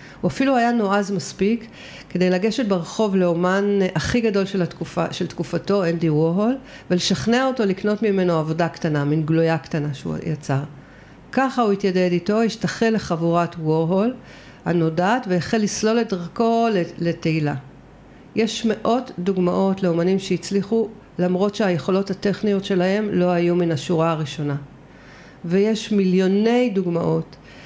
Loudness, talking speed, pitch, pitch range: -21 LUFS, 125 wpm, 185 Hz, 170-210 Hz